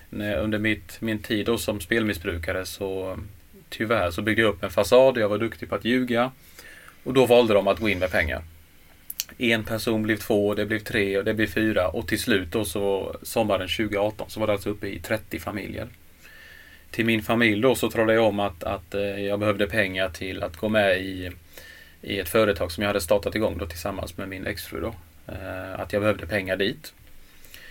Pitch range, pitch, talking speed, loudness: 95-110 Hz, 105 Hz, 205 wpm, -24 LUFS